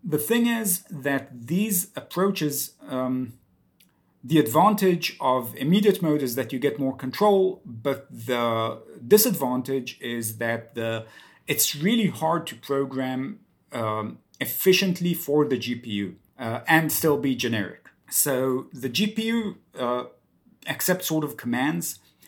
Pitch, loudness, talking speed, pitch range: 140 Hz, -24 LUFS, 125 wpm, 120-180 Hz